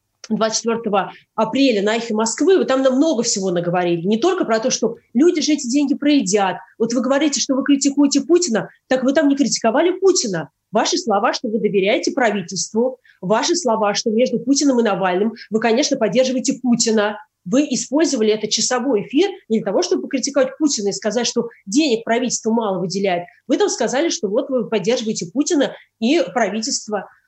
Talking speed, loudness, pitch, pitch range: 175 wpm, -18 LUFS, 235 Hz, 215-280 Hz